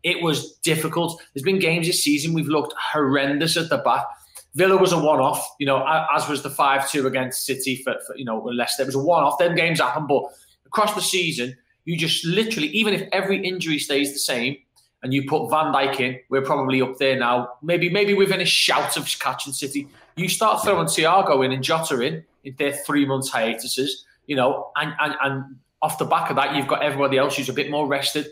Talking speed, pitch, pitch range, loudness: 220 wpm, 145 Hz, 135-170 Hz, -21 LUFS